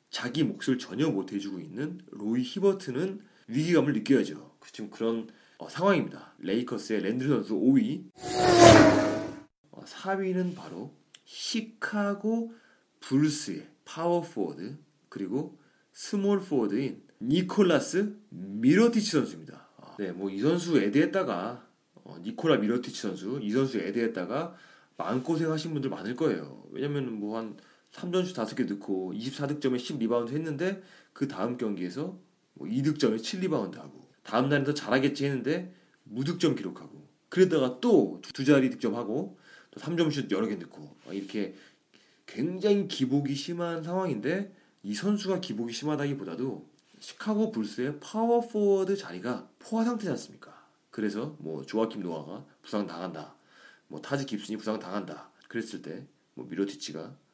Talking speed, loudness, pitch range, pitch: 300 characters per minute, -29 LUFS, 115-195 Hz, 150 Hz